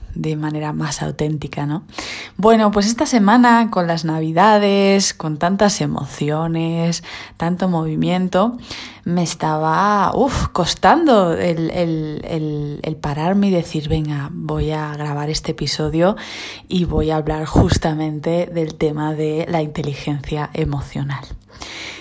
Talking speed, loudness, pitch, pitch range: 120 wpm, -18 LUFS, 160 Hz, 155-180 Hz